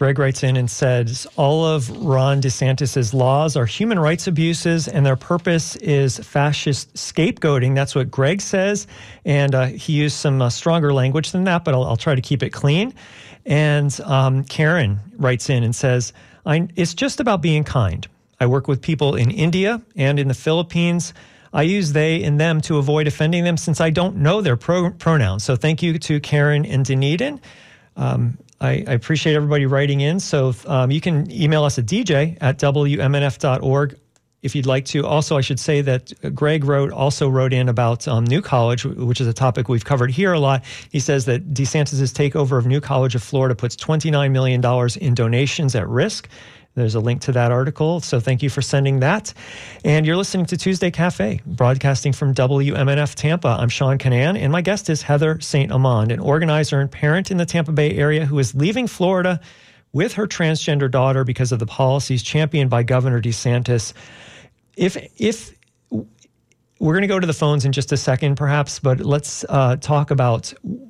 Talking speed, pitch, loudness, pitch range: 190 wpm, 140 Hz, -18 LUFS, 130-155 Hz